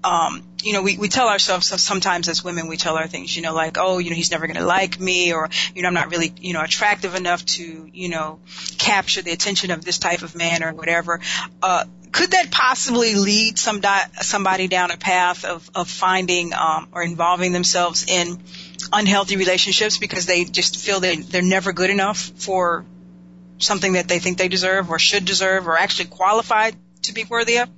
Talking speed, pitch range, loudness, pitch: 205 wpm, 175-195 Hz, -19 LUFS, 180 Hz